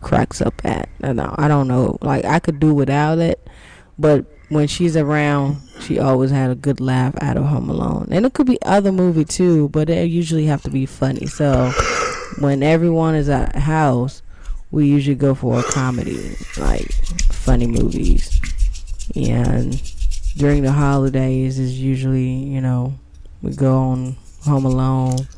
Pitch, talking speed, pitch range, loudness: 135 Hz, 165 wpm, 125-150 Hz, -18 LUFS